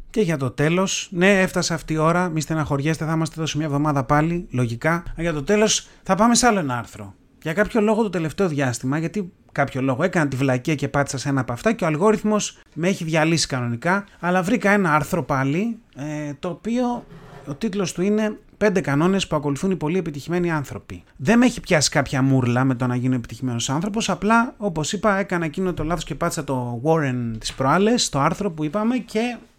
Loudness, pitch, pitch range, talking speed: -21 LUFS, 160 Hz, 140-195 Hz, 210 wpm